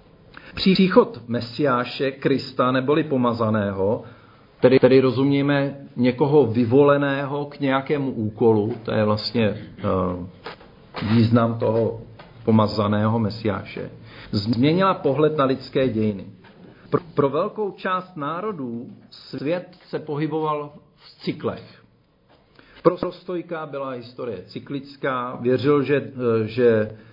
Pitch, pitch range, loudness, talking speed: 130 Hz, 115-145 Hz, -22 LUFS, 95 wpm